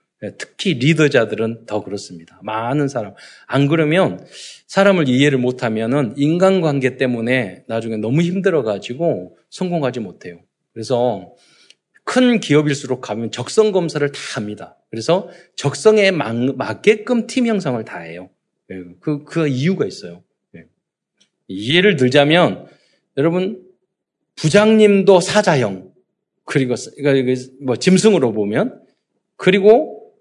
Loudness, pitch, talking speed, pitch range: -17 LUFS, 145 Hz, 270 characters per minute, 120-185 Hz